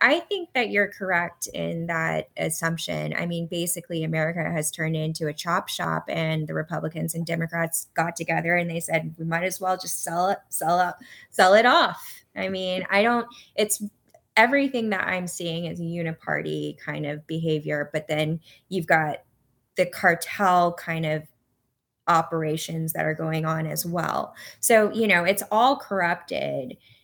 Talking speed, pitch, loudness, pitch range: 170 wpm, 165 Hz, -24 LUFS, 155-185 Hz